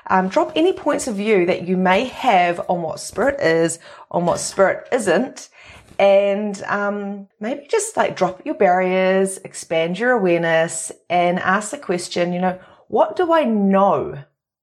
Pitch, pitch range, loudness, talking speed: 190 Hz, 175-235 Hz, -19 LUFS, 160 wpm